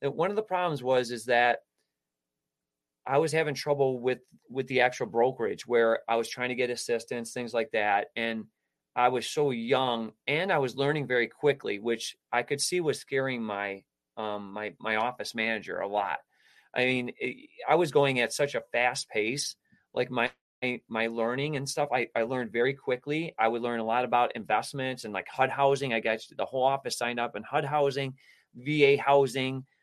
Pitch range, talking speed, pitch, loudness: 115-140 Hz, 195 wpm, 125 Hz, -29 LUFS